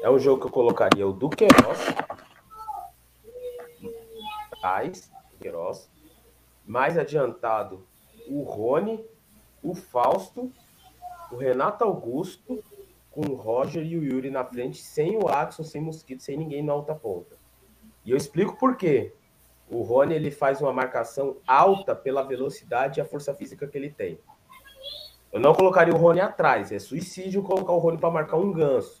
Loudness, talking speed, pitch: -24 LUFS, 150 wpm, 190 Hz